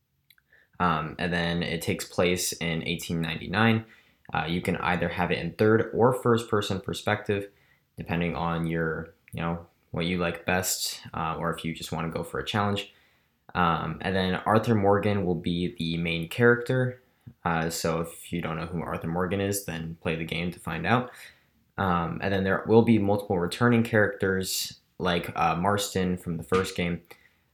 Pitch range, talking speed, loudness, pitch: 85-100 Hz, 180 wpm, -27 LUFS, 90 Hz